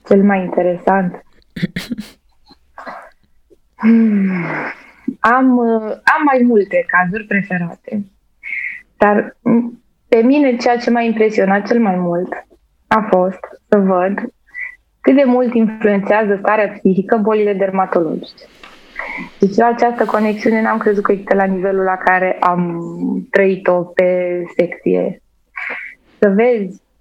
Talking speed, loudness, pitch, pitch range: 110 wpm, -15 LUFS, 205 Hz, 185-235 Hz